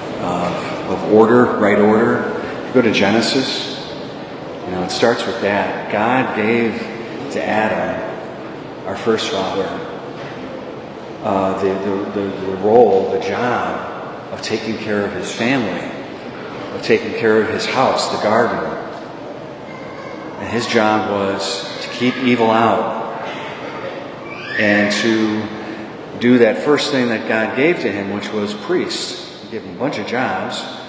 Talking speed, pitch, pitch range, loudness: 140 wpm, 110 Hz, 100-115 Hz, -17 LUFS